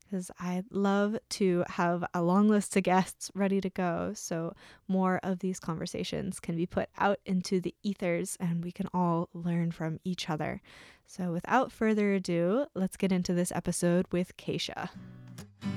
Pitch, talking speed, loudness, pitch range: 180 Hz, 165 wpm, -31 LUFS, 175-195 Hz